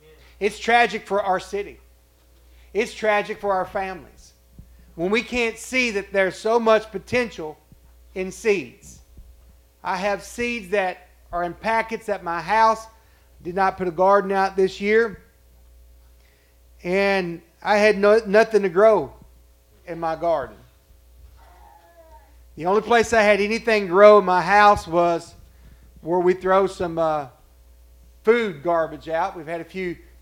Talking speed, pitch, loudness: 145 wpm, 185 Hz, -21 LUFS